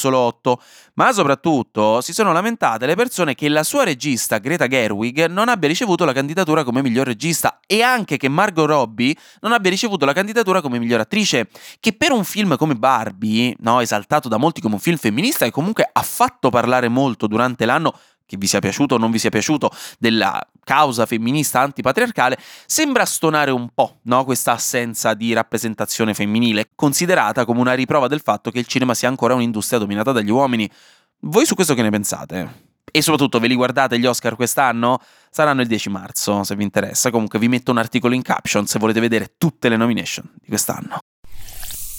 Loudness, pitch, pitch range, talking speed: -18 LUFS, 125 Hz, 115-155 Hz, 185 wpm